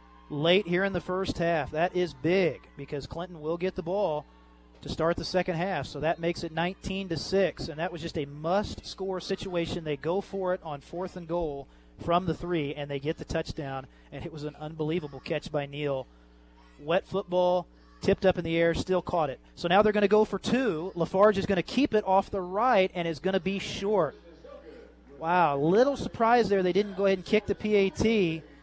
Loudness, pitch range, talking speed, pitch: -28 LUFS, 155-190 Hz, 220 wpm, 175 Hz